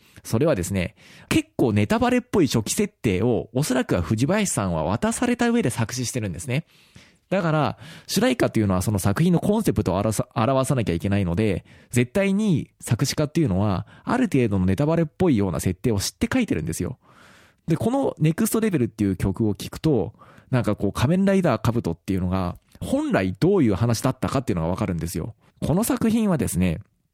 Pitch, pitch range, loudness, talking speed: 120 Hz, 100-165 Hz, -23 LUFS, 425 characters per minute